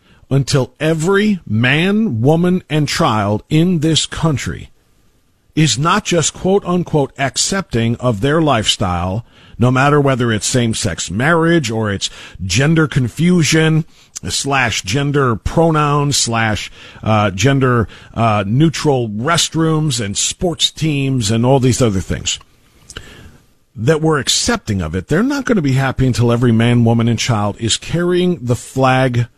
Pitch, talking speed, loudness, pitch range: 130 Hz, 135 wpm, -15 LUFS, 115-160 Hz